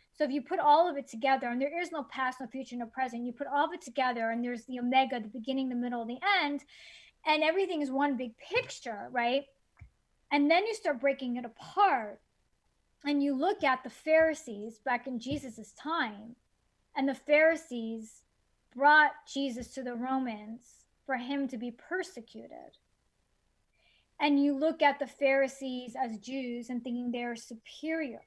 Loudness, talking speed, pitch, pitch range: -31 LUFS, 175 wpm, 265 Hz, 245-295 Hz